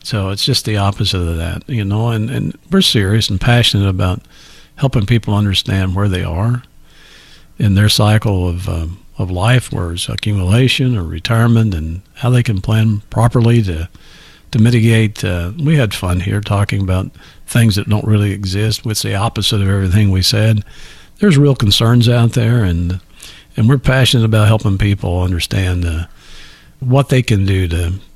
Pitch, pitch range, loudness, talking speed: 105 Hz, 95-115 Hz, -14 LUFS, 175 wpm